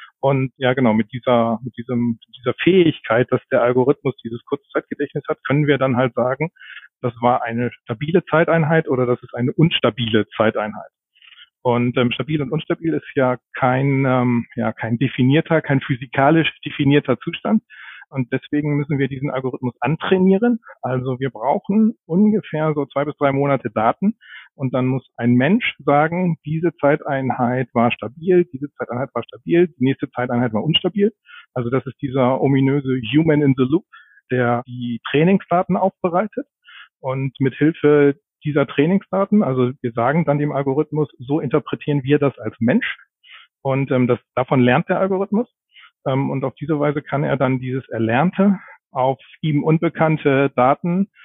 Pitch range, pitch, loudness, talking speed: 125-160 Hz, 140 Hz, -19 LUFS, 155 wpm